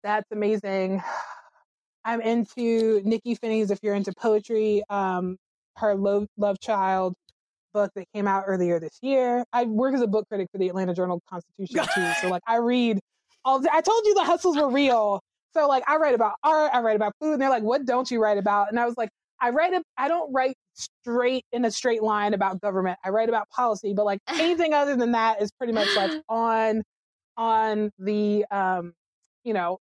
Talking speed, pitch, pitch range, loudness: 205 wpm, 220 Hz, 200-250 Hz, -24 LUFS